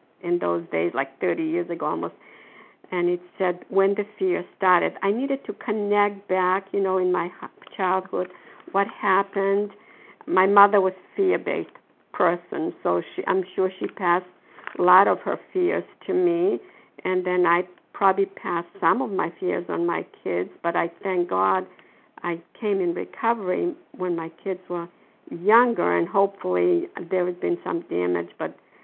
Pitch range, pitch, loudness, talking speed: 175-200 Hz, 185 Hz, -24 LUFS, 165 wpm